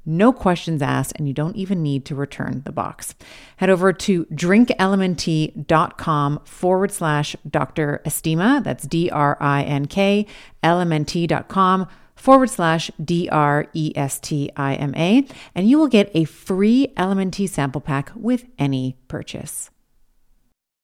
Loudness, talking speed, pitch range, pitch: -20 LUFS, 155 wpm, 145-195 Hz, 165 Hz